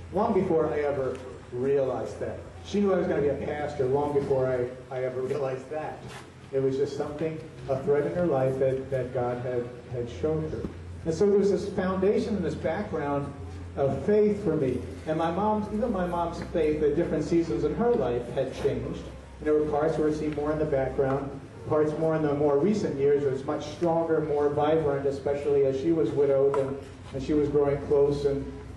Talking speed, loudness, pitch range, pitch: 210 wpm, -27 LUFS, 135-160 Hz, 145 Hz